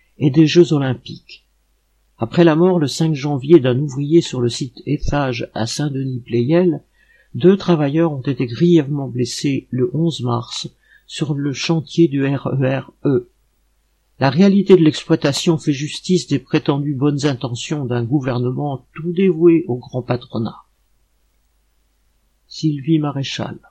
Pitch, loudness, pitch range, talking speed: 145 Hz, -17 LUFS, 125-160 Hz, 130 wpm